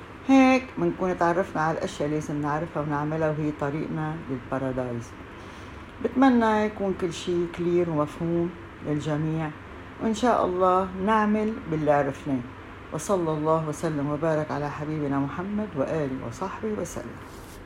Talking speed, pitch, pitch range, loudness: 120 wpm, 155 Hz, 145-185 Hz, -26 LUFS